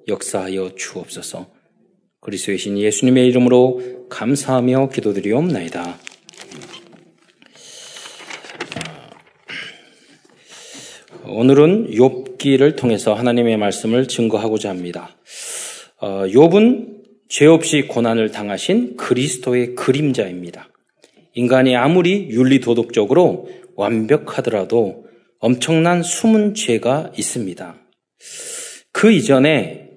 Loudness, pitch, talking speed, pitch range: -16 LUFS, 125 Hz, 230 characters per minute, 110-160 Hz